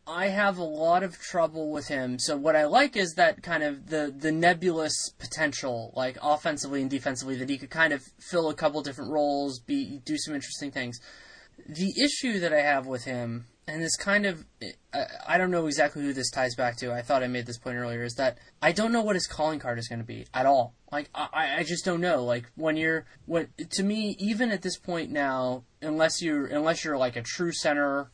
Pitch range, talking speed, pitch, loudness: 130-175 Hz, 230 wpm, 155 Hz, -28 LUFS